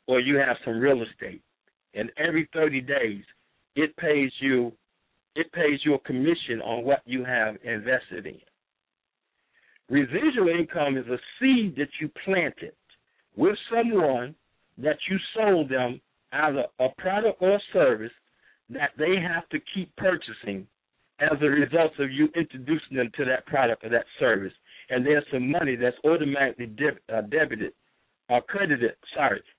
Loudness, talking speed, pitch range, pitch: -25 LUFS, 150 wpm, 125-165 Hz, 145 Hz